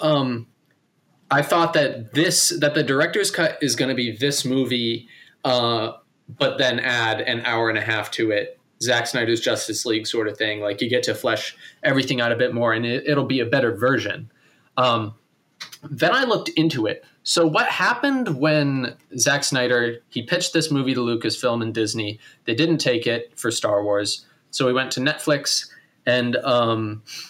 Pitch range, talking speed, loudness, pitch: 115-145 Hz, 185 wpm, -21 LUFS, 125 Hz